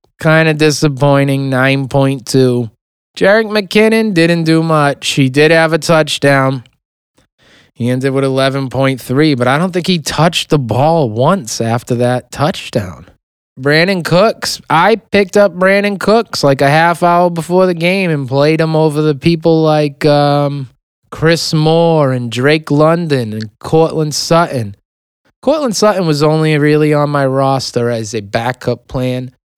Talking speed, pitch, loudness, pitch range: 145 wpm, 150 Hz, -12 LUFS, 135-165 Hz